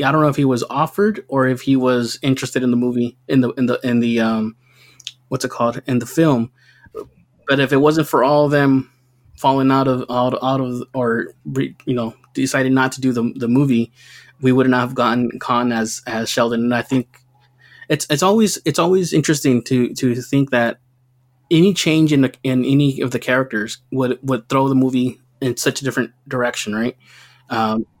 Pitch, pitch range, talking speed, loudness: 130 Hz, 120-135 Hz, 205 wpm, -18 LUFS